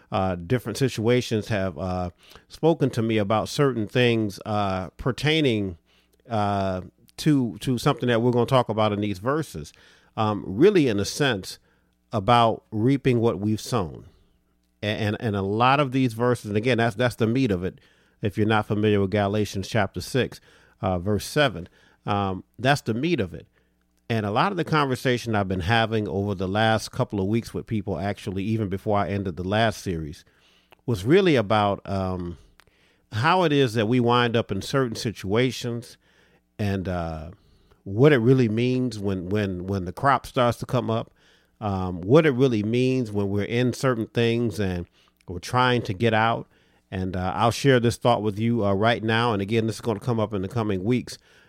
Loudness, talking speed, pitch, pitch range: -24 LUFS, 190 wpm, 110 Hz, 95-120 Hz